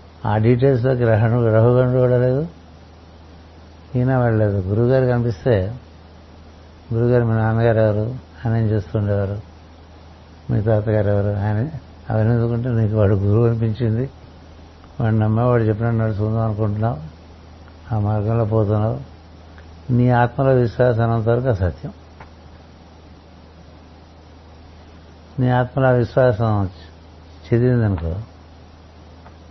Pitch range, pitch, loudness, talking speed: 80-115 Hz, 105 Hz, -19 LUFS, 90 wpm